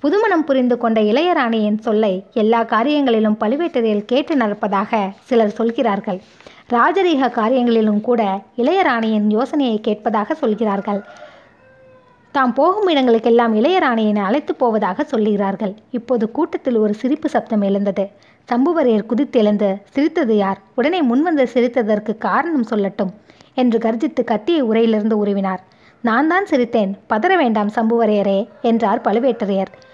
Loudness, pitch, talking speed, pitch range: -17 LUFS, 230 Hz, 110 wpm, 210-260 Hz